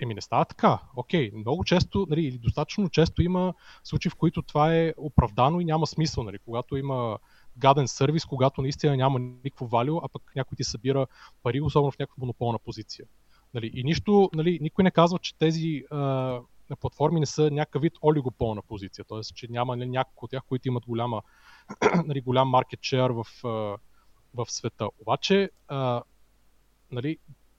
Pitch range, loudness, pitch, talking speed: 120-155 Hz, -26 LUFS, 135 Hz, 170 wpm